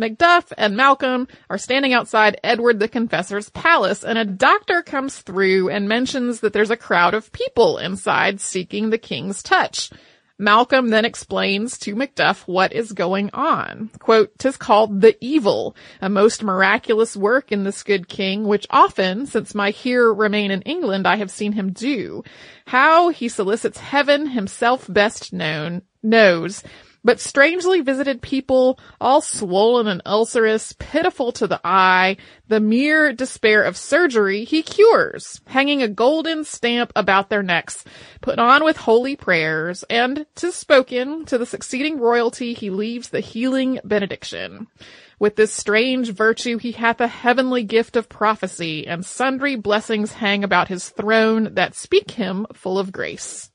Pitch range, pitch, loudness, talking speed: 200-260 Hz, 225 Hz, -18 LUFS, 155 wpm